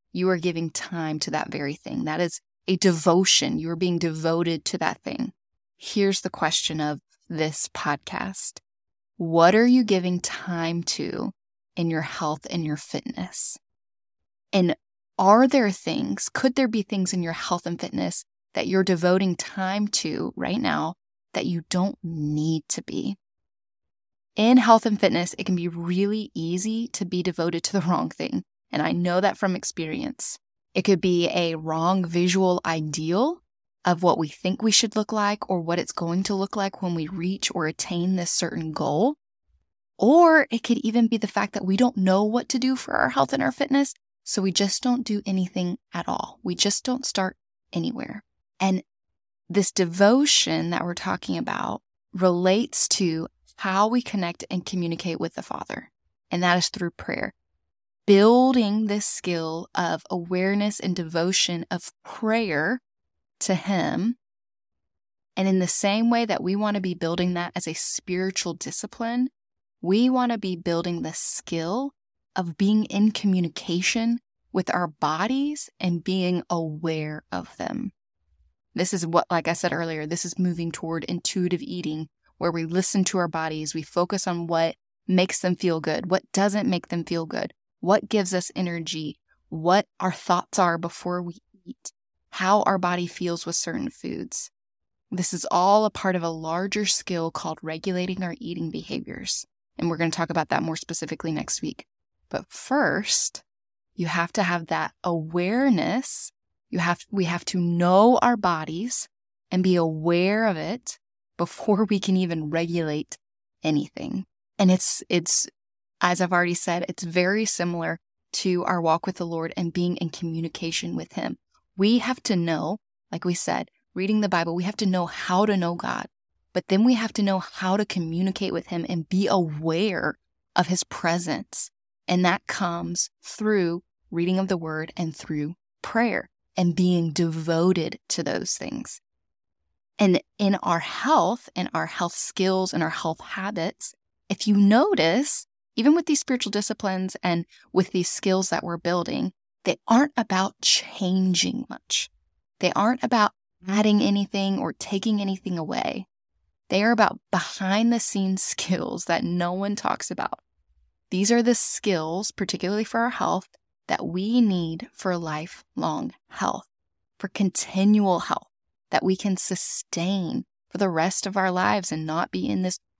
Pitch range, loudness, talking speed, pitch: 170-205 Hz, -24 LUFS, 165 wpm, 180 Hz